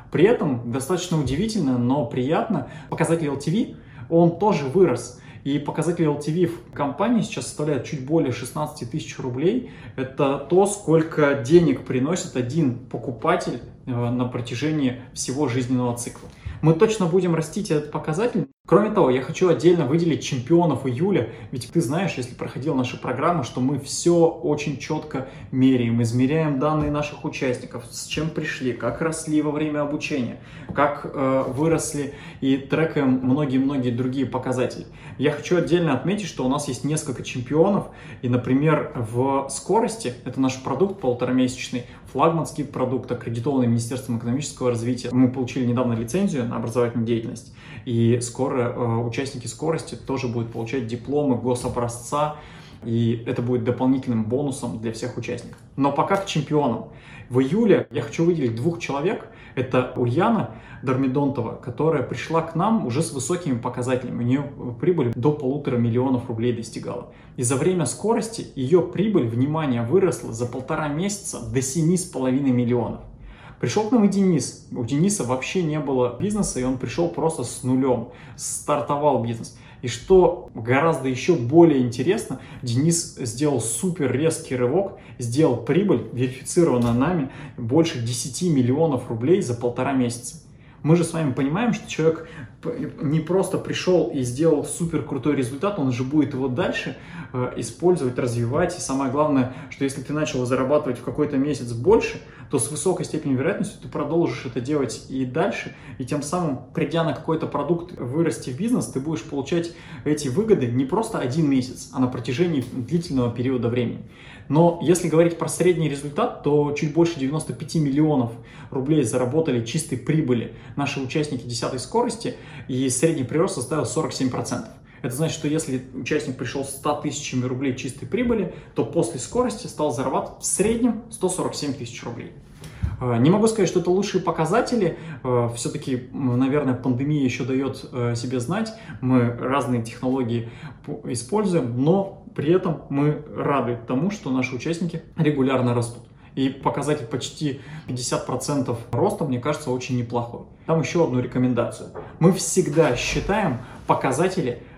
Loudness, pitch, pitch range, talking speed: -23 LUFS, 140 Hz, 125-160 Hz, 145 wpm